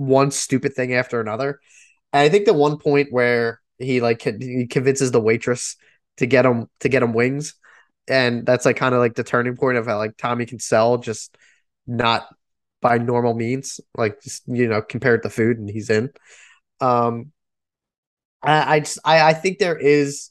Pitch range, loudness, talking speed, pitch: 120-140 Hz, -19 LUFS, 185 wpm, 125 Hz